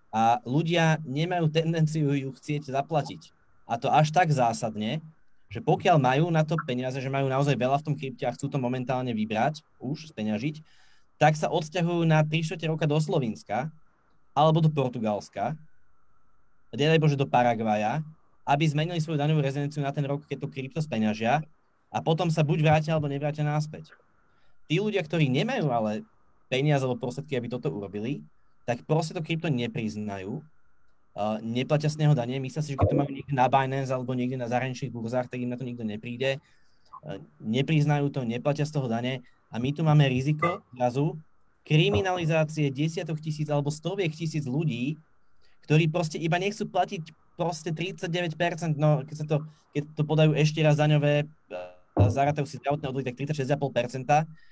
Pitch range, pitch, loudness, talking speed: 125-155 Hz, 145 Hz, -27 LUFS, 165 wpm